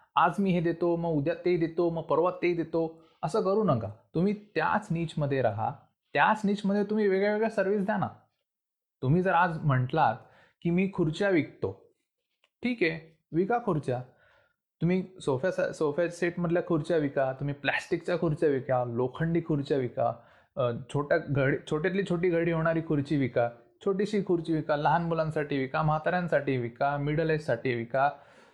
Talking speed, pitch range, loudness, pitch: 155 wpm, 145-185 Hz, -29 LUFS, 165 Hz